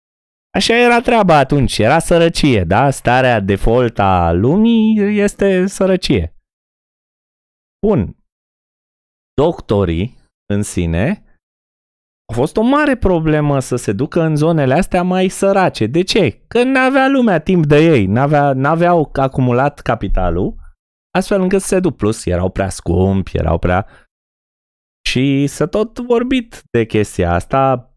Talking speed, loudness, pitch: 130 wpm, -14 LUFS, 140 Hz